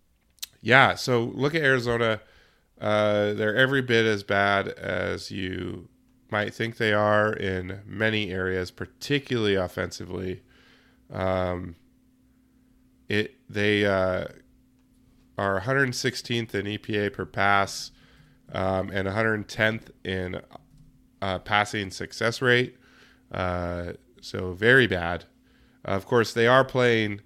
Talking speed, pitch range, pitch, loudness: 110 wpm, 95-120 Hz, 105 Hz, -25 LUFS